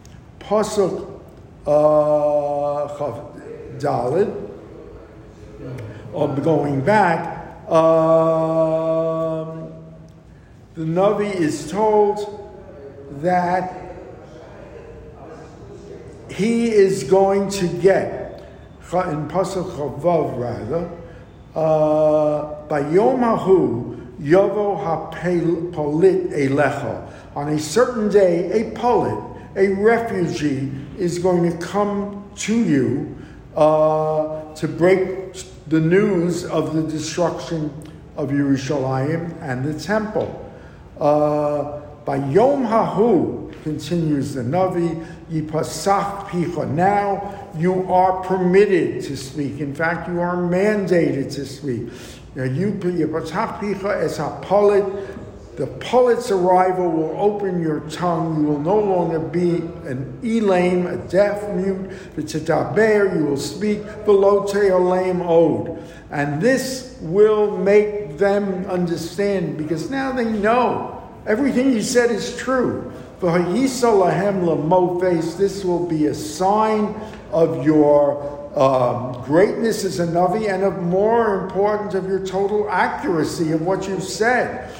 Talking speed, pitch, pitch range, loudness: 105 wpm, 175 Hz, 155-200 Hz, -19 LUFS